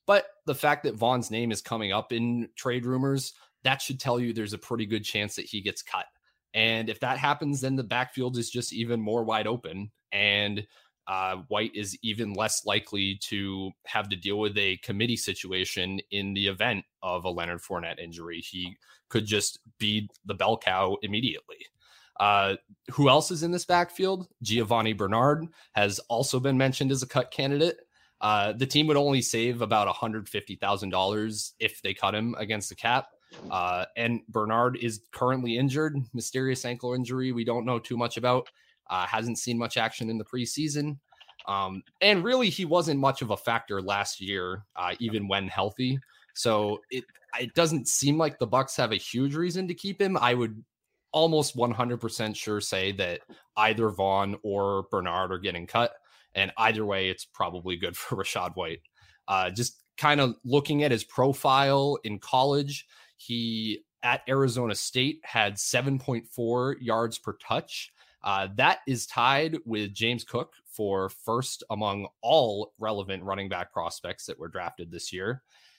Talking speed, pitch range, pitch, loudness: 170 wpm, 105-130 Hz, 115 Hz, -28 LUFS